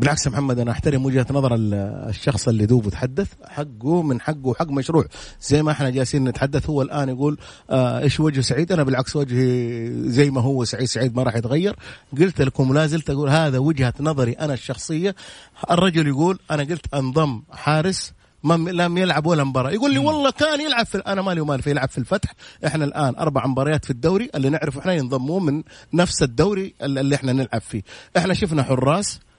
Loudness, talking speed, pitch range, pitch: -21 LUFS, 185 wpm, 130-160 Hz, 145 Hz